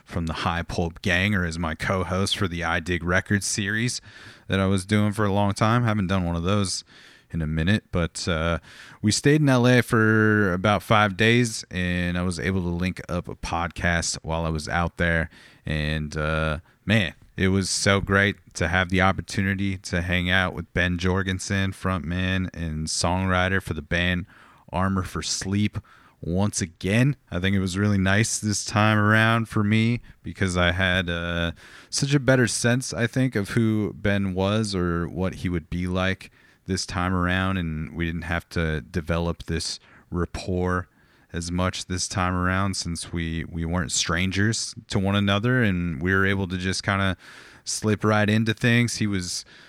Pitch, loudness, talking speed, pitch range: 95 Hz, -24 LUFS, 185 wpm, 85-105 Hz